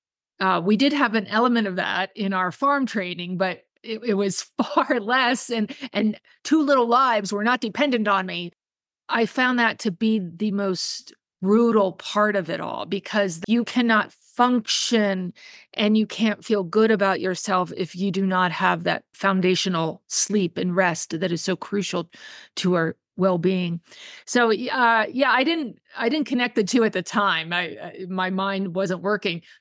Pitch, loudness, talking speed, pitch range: 205 Hz, -22 LUFS, 180 wpm, 185-235 Hz